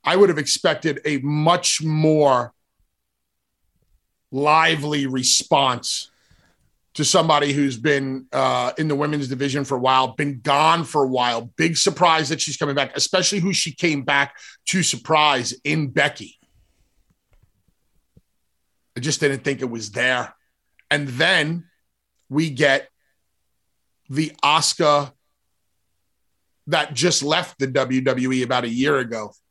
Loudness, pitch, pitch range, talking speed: -20 LUFS, 145 Hz, 130-155 Hz, 130 wpm